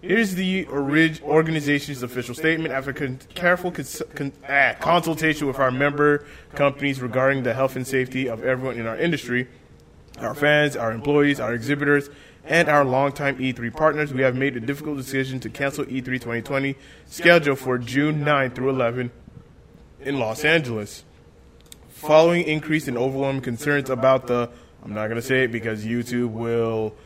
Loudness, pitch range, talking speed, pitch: -22 LUFS, 125-150 Hz, 160 wpm, 135 Hz